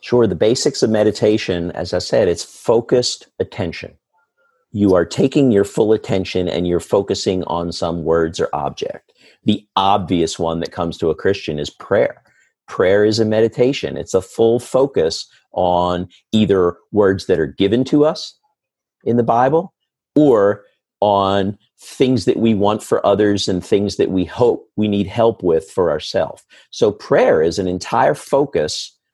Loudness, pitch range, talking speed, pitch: -17 LUFS, 90-120 Hz, 165 wpm, 105 Hz